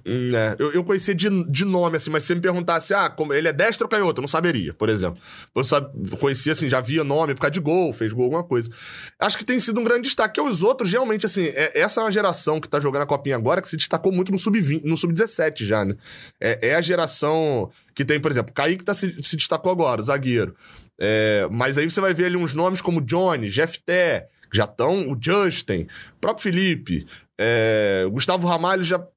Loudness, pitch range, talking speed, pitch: -21 LUFS, 140-185 Hz, 230 wpm, 160 Hz